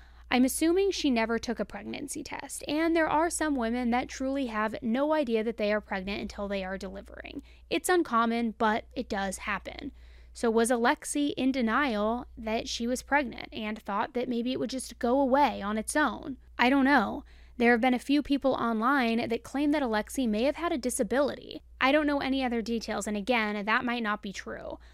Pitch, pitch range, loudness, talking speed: 245 Hz, 225-285 Hz, -28 LUFS, 205 wpm